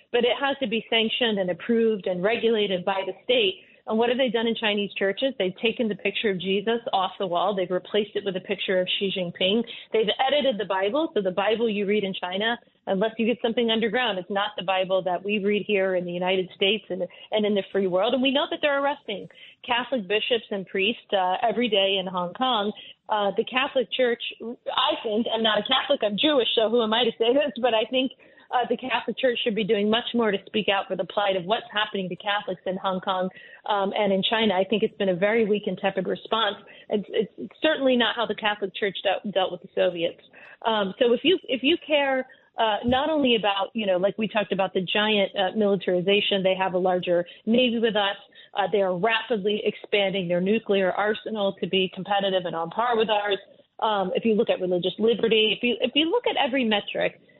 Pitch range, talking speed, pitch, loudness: 195-235 Hz, 230 wpm, 210 Hz, -24 LUFS